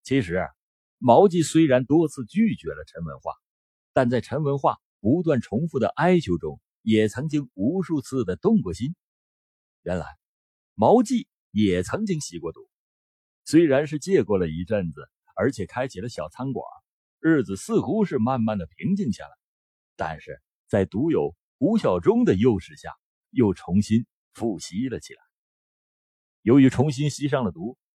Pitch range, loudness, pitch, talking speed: 110-175 Hz, -23 LUFS, 140 Hz, 225 characters per minute